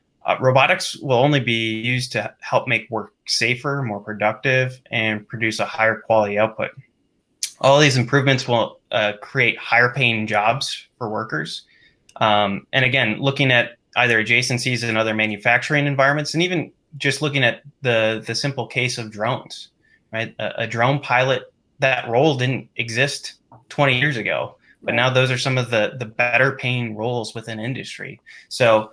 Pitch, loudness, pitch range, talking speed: 120 Hz, -19 LUFS, 110-135 Hz, 160 wpm